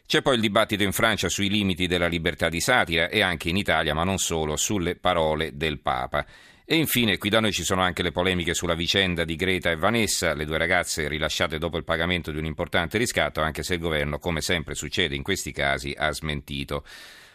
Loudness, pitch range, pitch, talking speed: -24 LUFS, 80-95 Hz, 85 Hz, 215 wpm